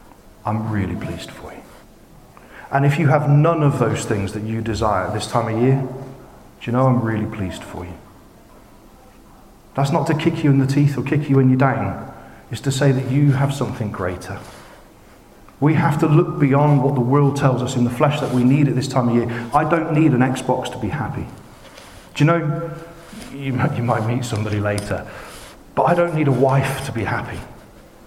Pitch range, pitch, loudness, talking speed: 115-145 Hz, 130 Hz, -19 LUFS, 205 wpm